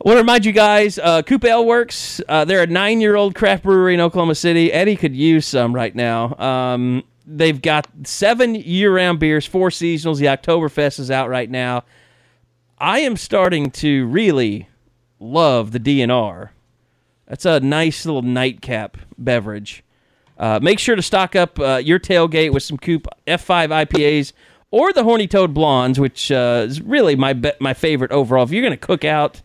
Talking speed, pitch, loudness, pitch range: 175 wpm, 155 Hz, -16 LUFS, 130-180 Hz